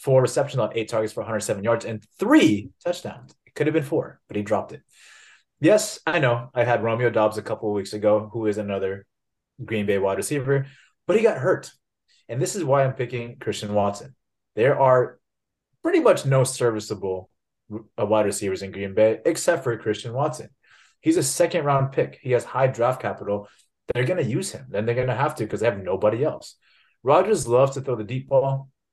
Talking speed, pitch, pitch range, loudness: 205 wpm, 120 Hz, 105-135 Hz, -23 LUFS